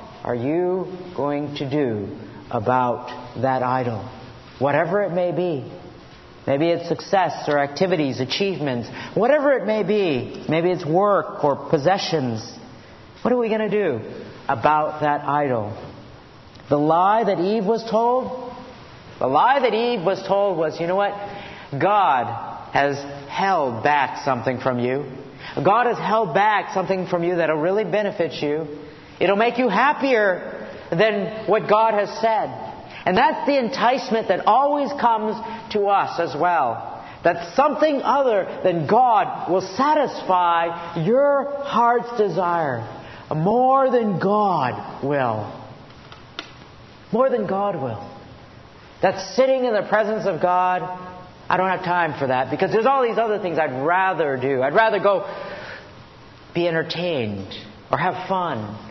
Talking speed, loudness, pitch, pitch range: 140 wpm, -21 LUFS, 180 Hz, 145-215 Hz